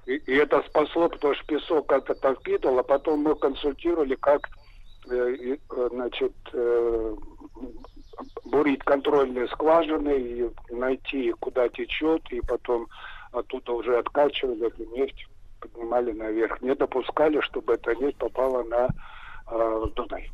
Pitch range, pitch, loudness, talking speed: 120-160 Hz, 130 Hz, -26 LUFS, 110 wpm